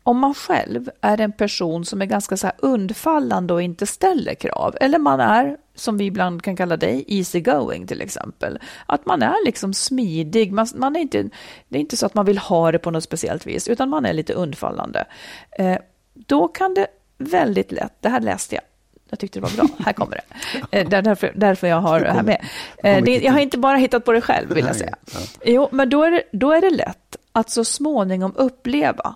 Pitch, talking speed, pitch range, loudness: 225 Hz, 220 wpm, 190-270 Hz, -19 LUFS